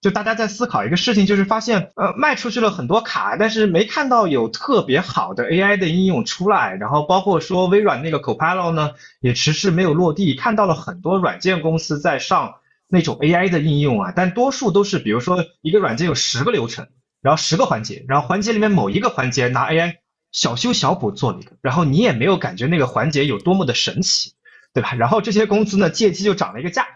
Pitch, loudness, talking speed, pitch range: 185 Hz, -18 LUFS, 365 characters per minute, 160-210 Hz